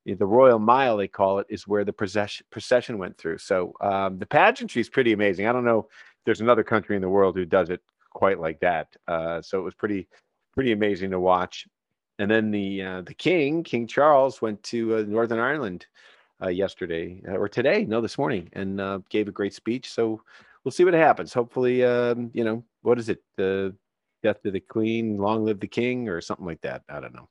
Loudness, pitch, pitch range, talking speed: -24 LUFS, 110 Hz, 100-115 Hz, 215 wpm